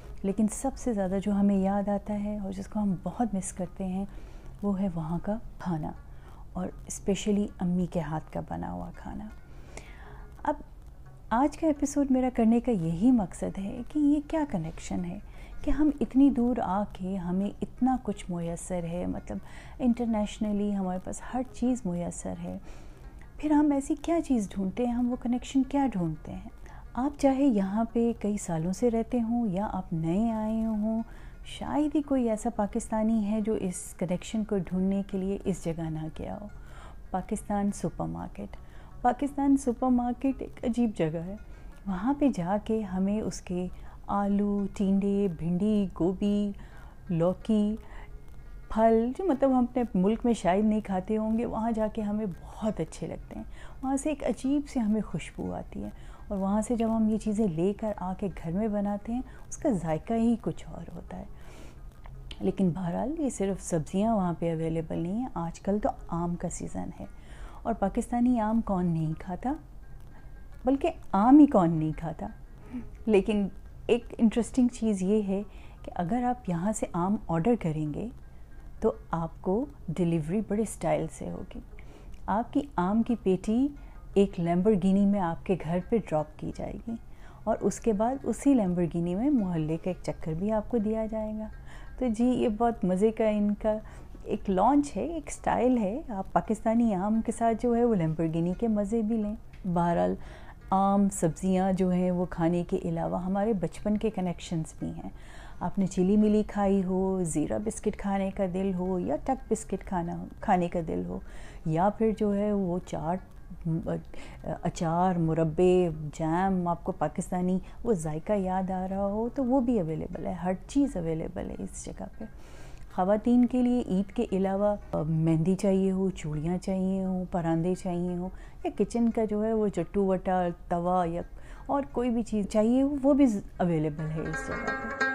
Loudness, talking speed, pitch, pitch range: -29 LUFS, 175 wpm, 200 Hz, 175-230 Hz